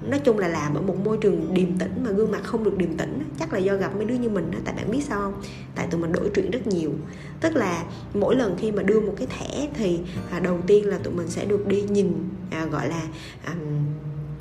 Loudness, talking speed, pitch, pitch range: -25 LUFS, 245 wpm, 185 Hz, 165-205 Hz